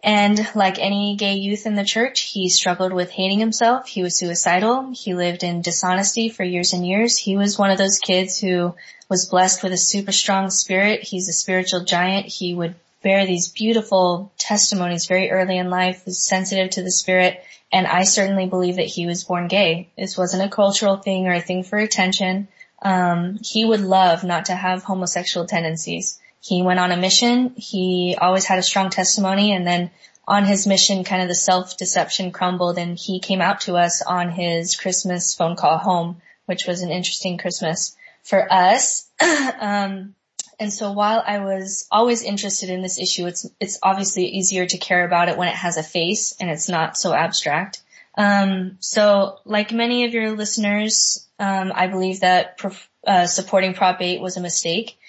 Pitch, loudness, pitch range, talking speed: 185 Hz, -19 LUFS, 180-200 Hz, 190 wpm